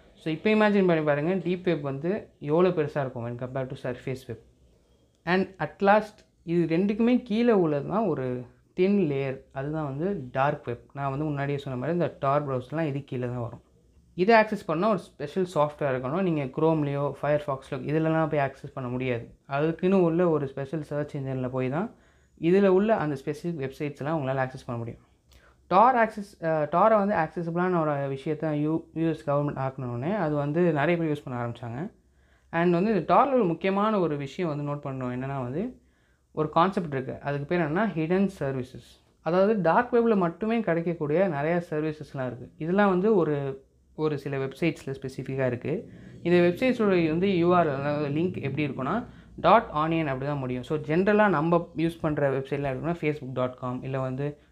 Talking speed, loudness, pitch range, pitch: 165 wpm, -26 LUFS, 135-175 Hz, 150 Hz